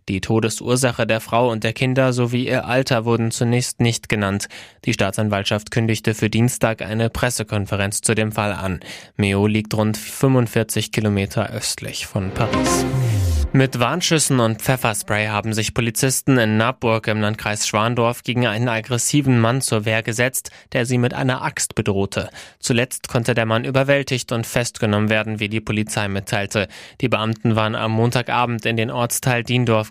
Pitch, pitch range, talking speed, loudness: 115 Hz, 110-125 Hz, 160 wpm, -19 LUFS